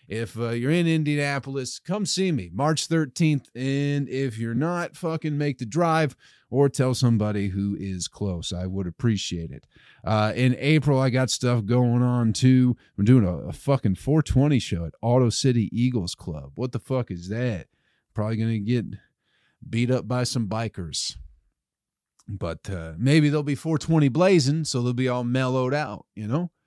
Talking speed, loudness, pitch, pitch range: 175 wpm, -24 LUFS, 125 Hz, 105-140 Hz